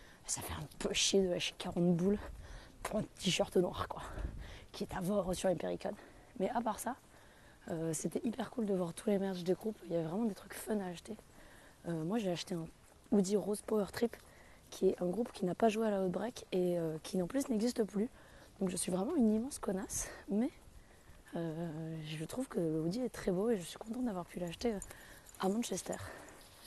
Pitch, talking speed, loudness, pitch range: 190 Hz, 215 wpm, -37 LUFS, 175-220 Hz